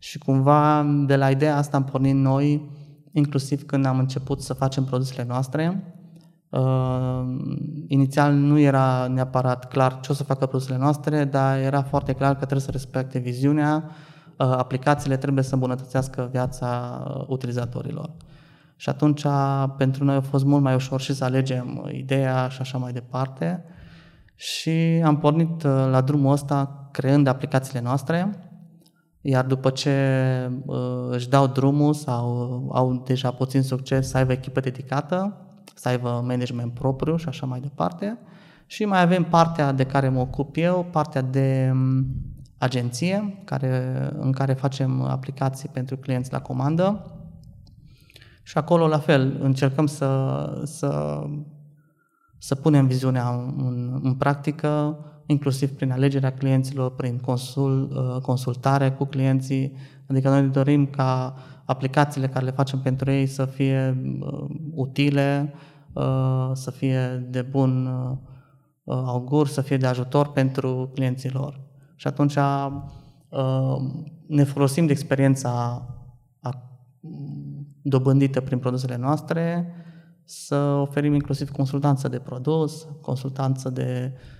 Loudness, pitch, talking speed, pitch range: -23 LUFS, 135 Hz, 125 wpm, 130-145 Hz